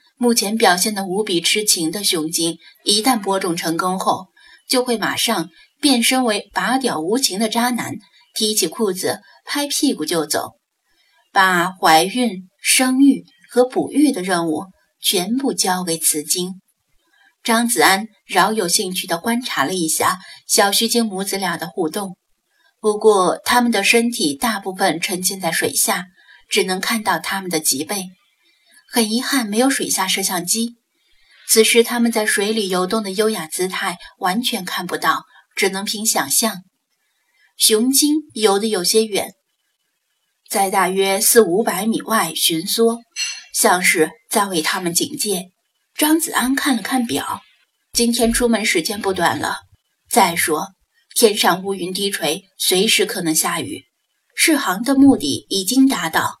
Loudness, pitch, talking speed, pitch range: -17 LUFS, 215 Hz, 215 characters per minute, 190-245 Hz